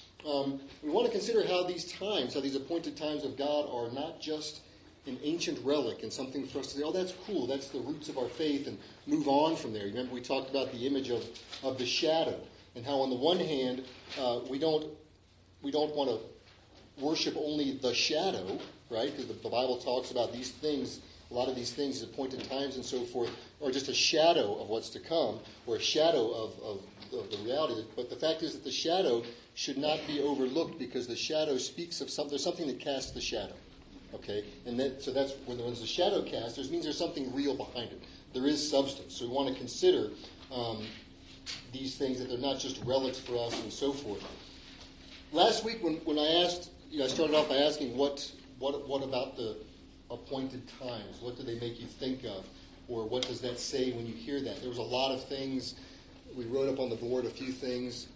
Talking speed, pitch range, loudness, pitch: 220 wpm, 125-150 Hz, -34 LUFS, 135 Hz